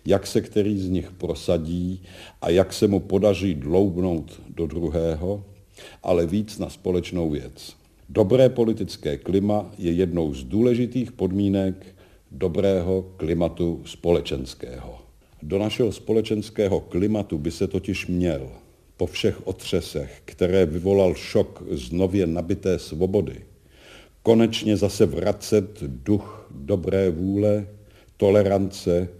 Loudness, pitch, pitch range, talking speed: -23 LUFS, 95 Hz, 85-105 Hz, 115 wpm